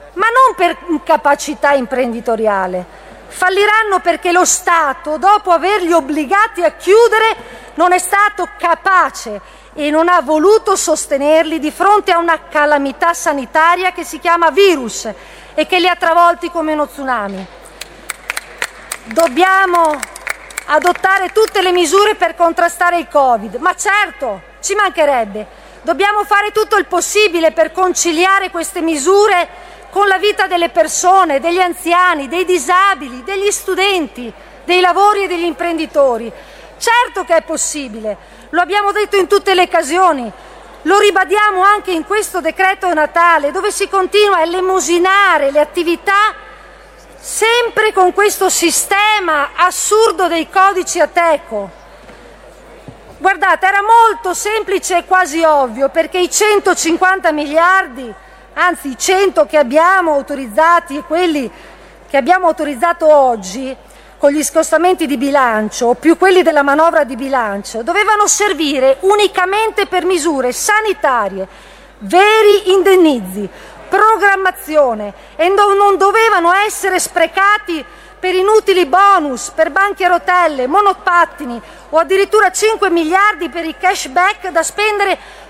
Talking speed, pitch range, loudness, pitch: 125 wpm, 305-390 Hz, -12 LUFS, 350 Hz